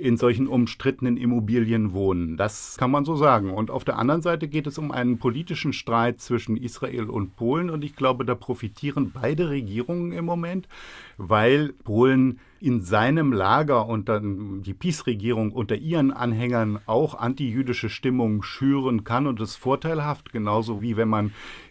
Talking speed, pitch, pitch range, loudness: 160 wpm, 125 Hz, 110-140 Hz, -24 LUFS